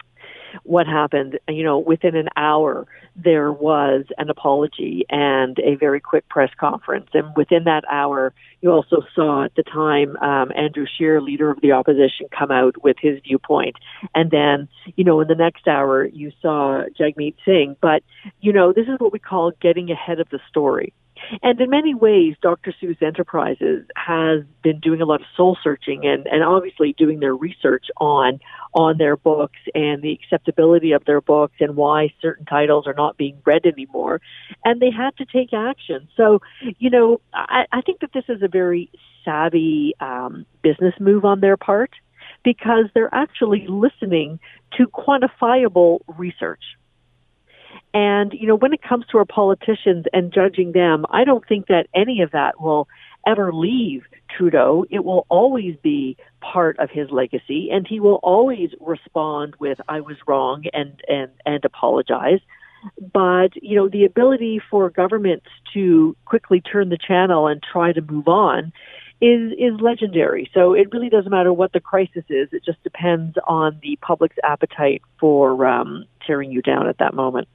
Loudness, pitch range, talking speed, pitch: -18 LUFS, 150-210 Hz, 175 wpm, 170 Hz